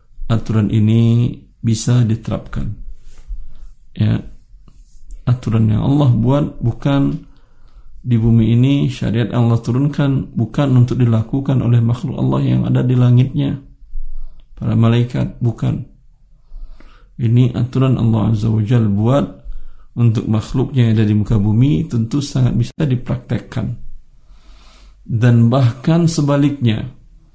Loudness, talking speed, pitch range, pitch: -16 LUFS, 110 wpm, 115-135 Hz, 120 Hz